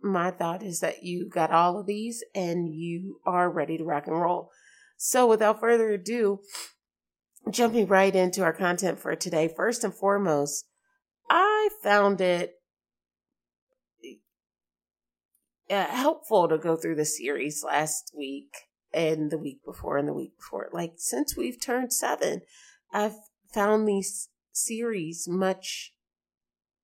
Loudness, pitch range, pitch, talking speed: -27 LUFS, 150-205 Hz, 175 Hz, 135 wpm